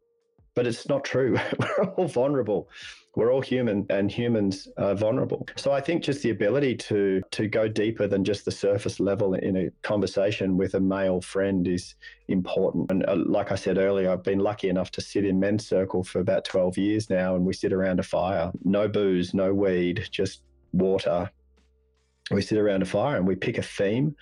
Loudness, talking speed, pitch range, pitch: -26 LUFS, 195 wpm, 95-105 Hz, 100 Hz